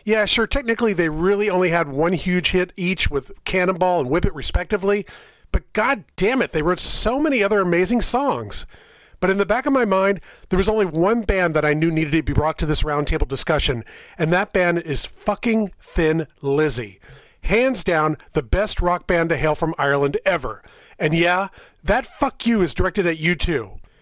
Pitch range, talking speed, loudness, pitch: 160-205 Hz, 195 wpm, -20 LUFS, 180 Hz